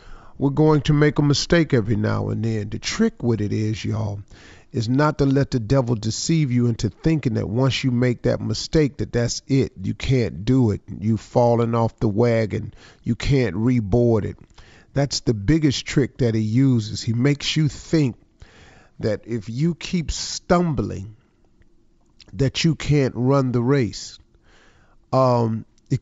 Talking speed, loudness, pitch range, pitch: 165 wpm, -21 LUFS, 110-140 Hz, 120 Hz